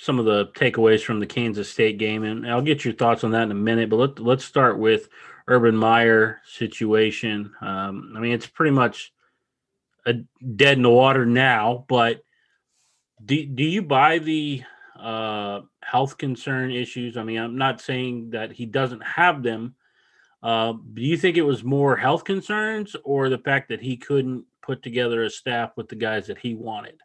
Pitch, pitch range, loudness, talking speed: 120 Hz, 115-135 Hz, -22 LUFS, 185 wpm